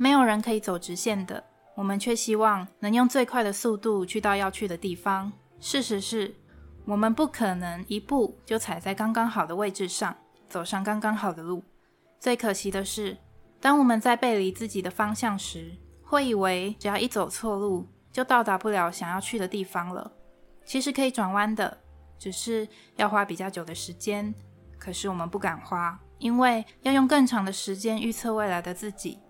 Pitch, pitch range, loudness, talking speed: 205 Hz, 190-225 Hz, -27 LUFS, 270 characters per minute